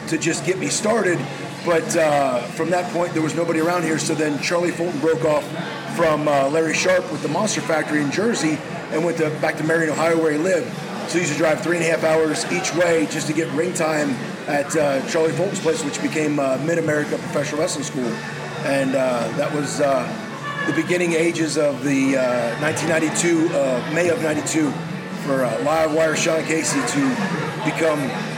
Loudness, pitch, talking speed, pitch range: -20 LUFS, 160 Hz, 200 wpm, 155-170 Hz